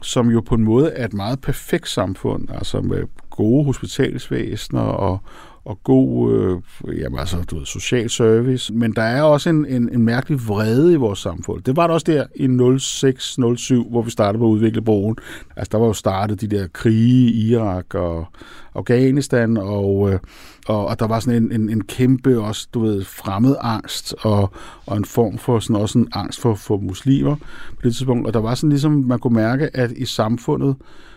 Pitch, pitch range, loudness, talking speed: 115 Hz, 105-130 Hz, -18 LUFS, 200 wpm